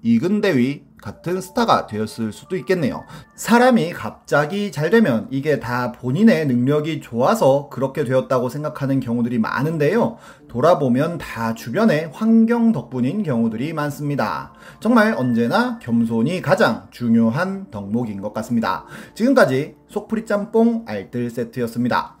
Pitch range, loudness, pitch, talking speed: 120-200 Hz, -19 LUFS, 145 Hz, 315 characters per minute